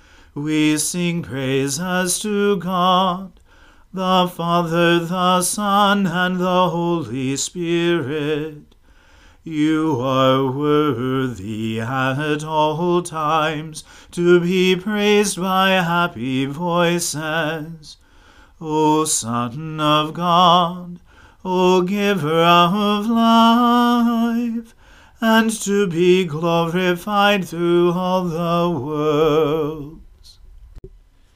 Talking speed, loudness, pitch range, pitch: 80 wpm, -18 LUFS, 150-185 Hz, 170 Hz